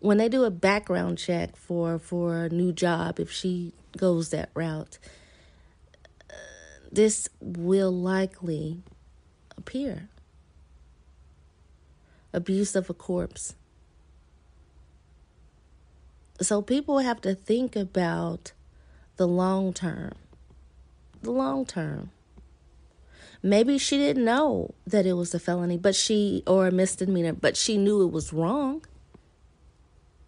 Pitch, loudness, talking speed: 165 Hz, -26 LUFS, 115 wpm